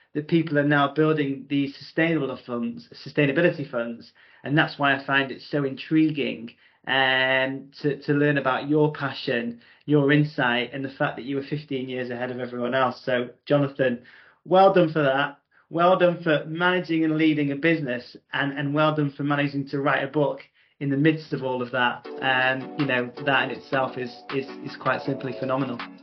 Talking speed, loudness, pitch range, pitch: 190 wpm, -24 LUFS, 130-150 Hz, 140 Hz